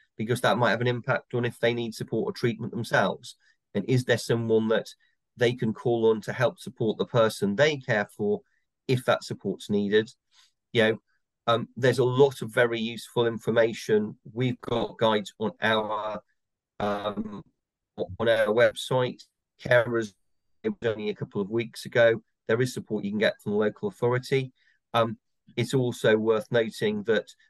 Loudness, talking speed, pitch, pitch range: -26 LUFS, 170 wpm, 120 Hz, 110-130 Hz